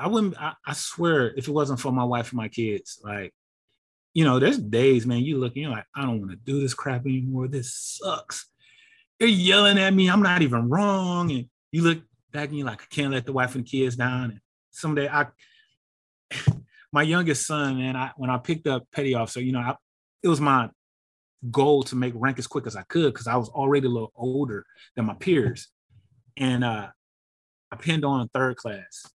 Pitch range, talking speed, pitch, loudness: 125-150 Hz, 220 wpm, 135 Hz, -24 LUFS